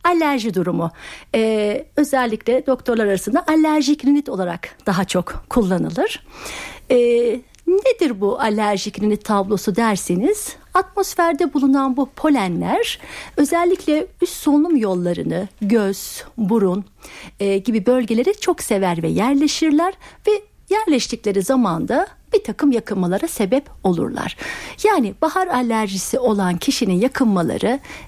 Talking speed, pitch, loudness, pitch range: 105 wpm, 245 Hz, -19 LUFS, 205-305 Hz